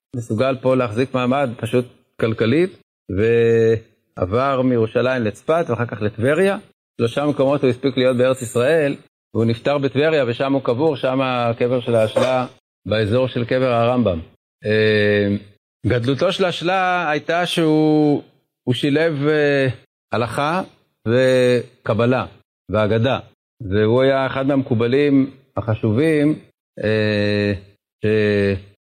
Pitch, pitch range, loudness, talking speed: 125 Hz, 110-140 Hz, -19 LUFS, 100 wpm